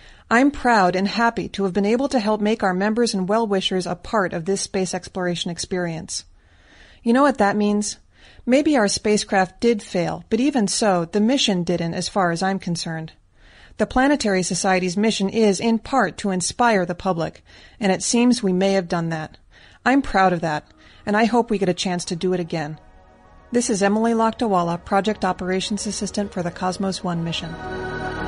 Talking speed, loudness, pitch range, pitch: 190 wpm, -21 LUFS, 180-225 Hz, 195 Hz